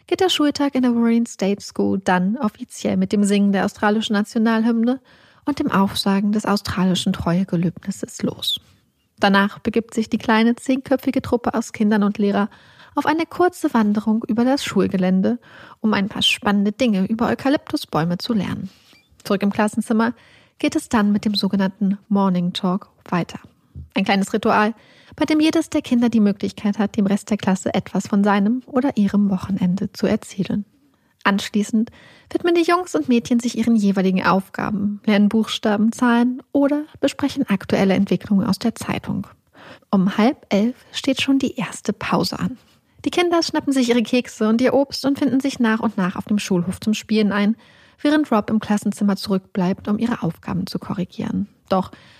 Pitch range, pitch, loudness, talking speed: 200-245 Hz, 215 Hz, -20 LUFS, 170 wpm